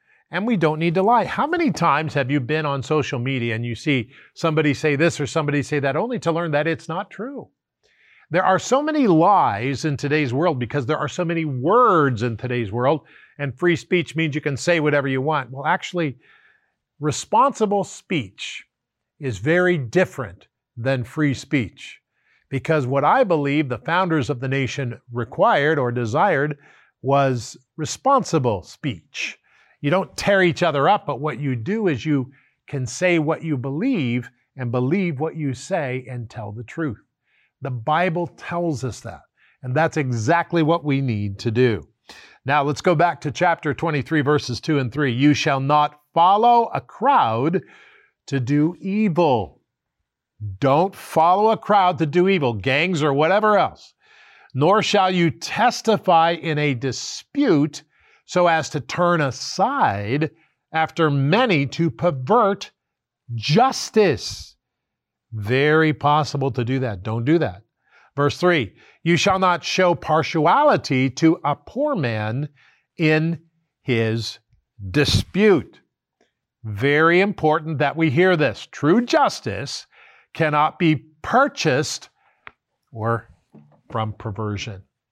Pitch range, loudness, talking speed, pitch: 130-175 Hz, -20 LUFS, 145 wpm, 150 Hz